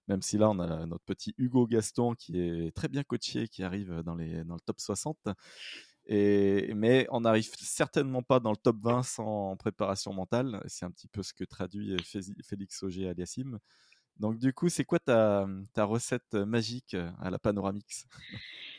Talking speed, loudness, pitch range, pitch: 190 wpm, -32 LUFS, 95-120 Hz, 105 Hz